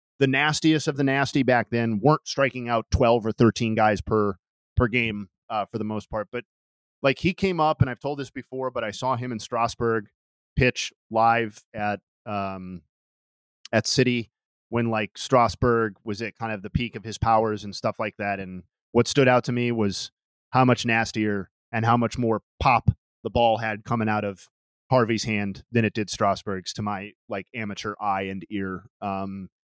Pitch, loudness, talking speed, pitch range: 110 Hz, -25 LUFS, 190 wpm, 100-120 Hz